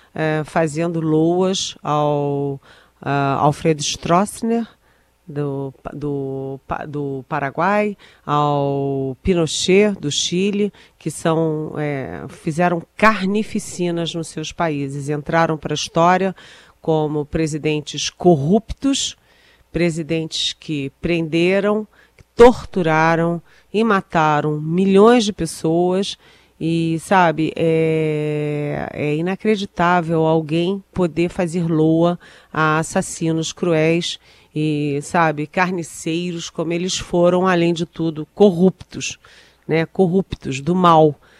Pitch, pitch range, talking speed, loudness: 165 Hz, 150-180 Hz, 95 wpm, -19 LUFS